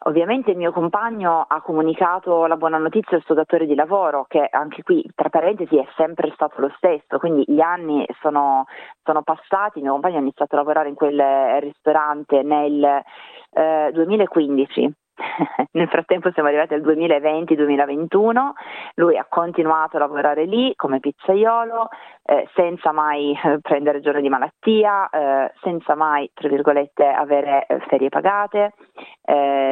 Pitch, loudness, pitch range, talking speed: 155 Hz, -19 LUFS, 145-175 Hz, 150 wpm